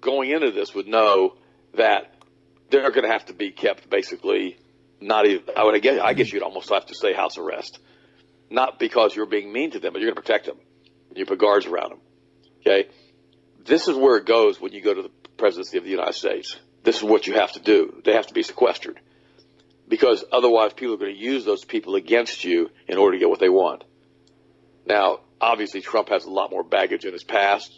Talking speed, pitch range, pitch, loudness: 225 wpm, 370-425 Hz, 400 Hz, -21 LUFS